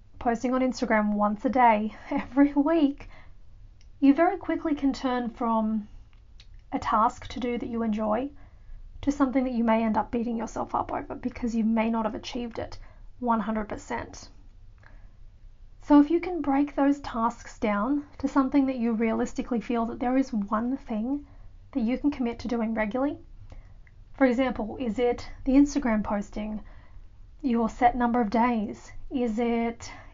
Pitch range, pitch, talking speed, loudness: 215-265 Hz, 235 Hz, 160 wpm, -27 LUFS